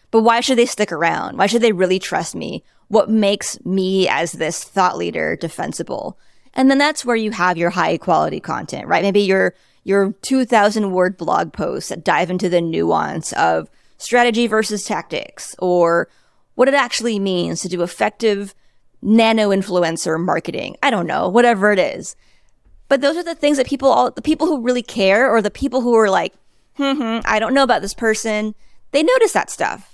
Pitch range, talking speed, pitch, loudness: 185-245 Hz, 185 wpm, 215 Hz, -17 LUFS